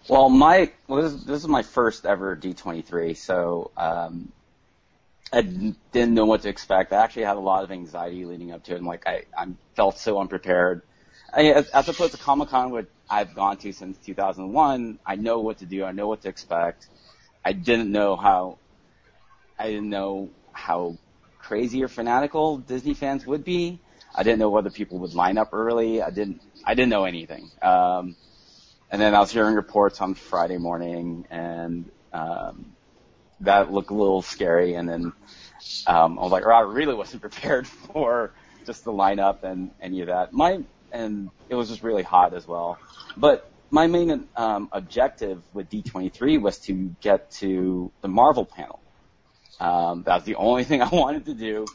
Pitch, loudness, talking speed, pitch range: 100 Hz, -23 LUFS, 185 wpm, 90-115 Hz